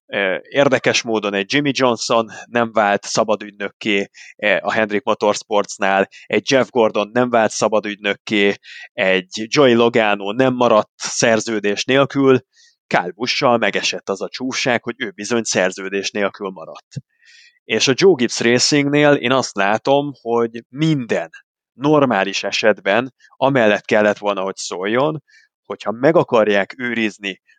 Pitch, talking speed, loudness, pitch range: 115 Hz, 125 wpm, -17 LUFS, 105-130 Hz